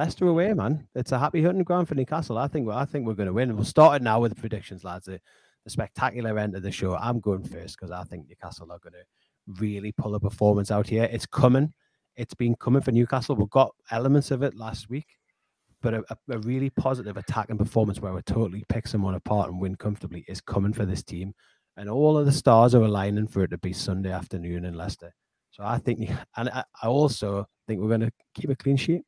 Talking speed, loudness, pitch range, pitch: 240 wpm, -25 LUFS, 100-130 Hz, 110 Hz